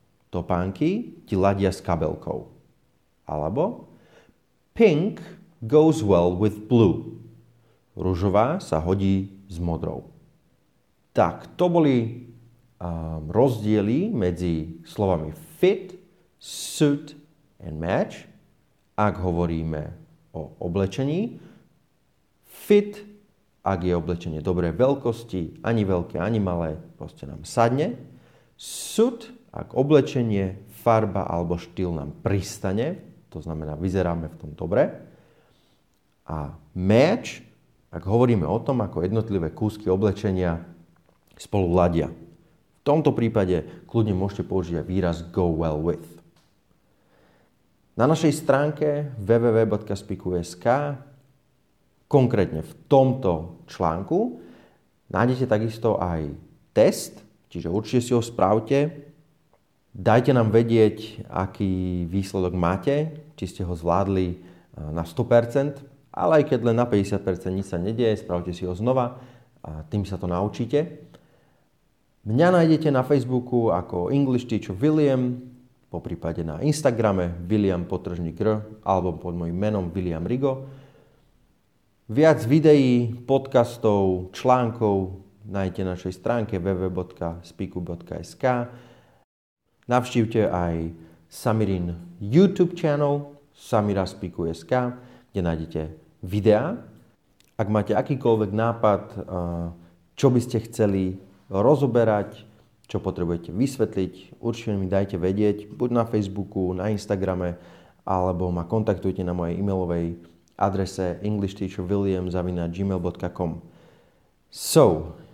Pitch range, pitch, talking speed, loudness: 90-125 Hz, 100 Hz, 100 wpm, -24 LUFS